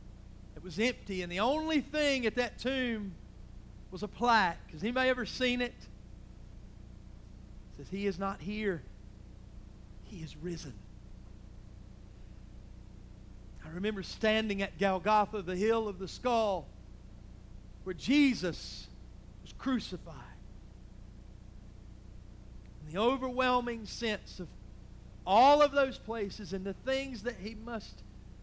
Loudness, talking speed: -32 LUFS, 120 wpm